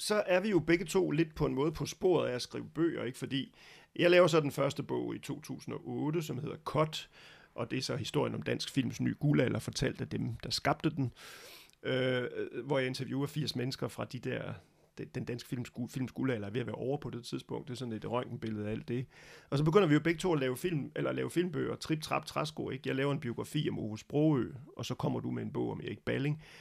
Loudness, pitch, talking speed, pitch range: -34 LUFS, 135 Hz, 250 wpm, 125-155 Hz